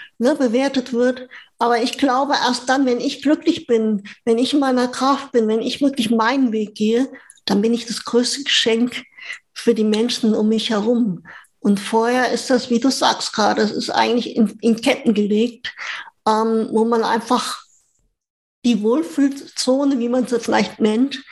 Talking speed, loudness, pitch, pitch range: 175 wpm, -18 LUFS, 240 Hz, 225-265 Hz